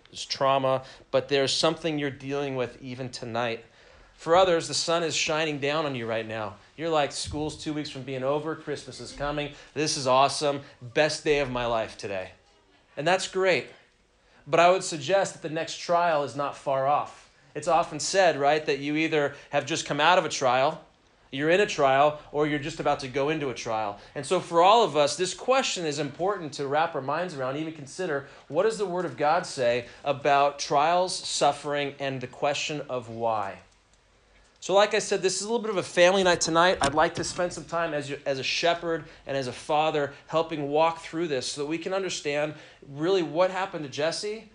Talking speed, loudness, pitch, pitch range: 215 wpm, -26 LUFS, 150 Hz, 135-170 Hz